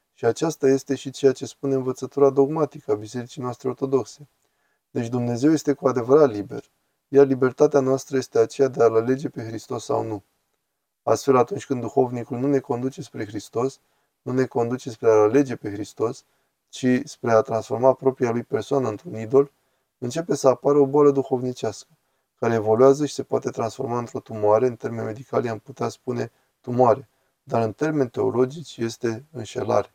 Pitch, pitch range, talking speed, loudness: 130 Hz, 120-140 Hz, 170 wpm, -23 LUFS